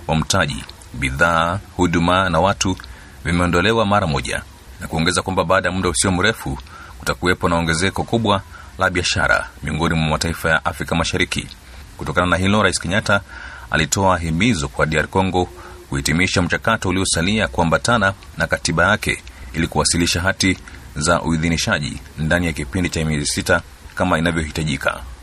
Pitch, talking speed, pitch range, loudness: 85 Hz, 140 wpm, 80-95 Hz, -18 LUFS